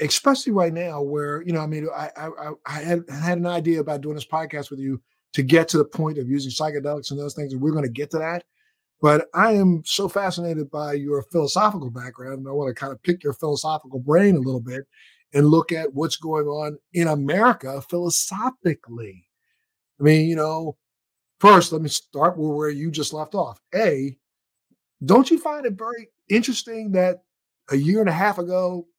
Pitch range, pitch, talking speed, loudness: 145-180 Hz, 155 Hz, 200 wpm, -22 LUFS